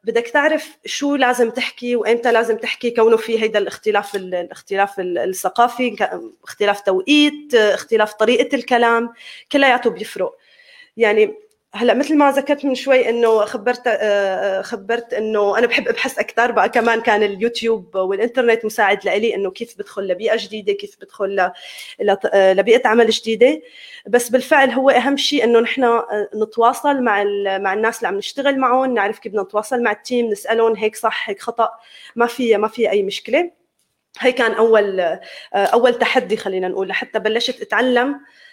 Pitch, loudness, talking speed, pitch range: 235 Hz, -17 LUFS, 150 wpm, 215-260 Hz